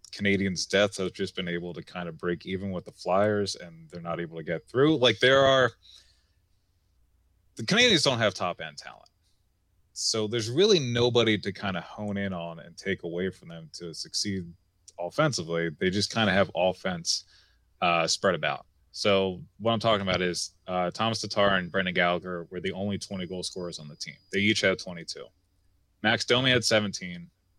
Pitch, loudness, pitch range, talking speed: 95 Hz, -26 LUFS, 90-105 Hz, 190 wpm